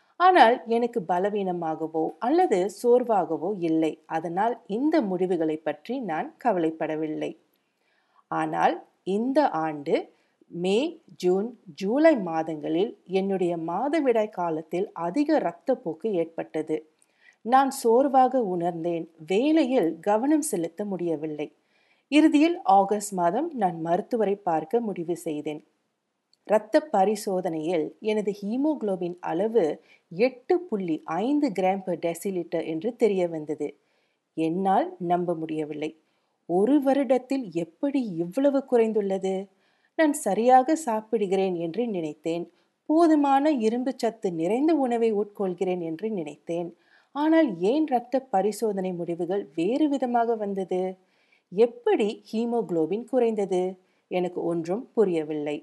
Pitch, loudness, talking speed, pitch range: 195 Hz, -25 LUFS, 95 wpm, 170-250 Hz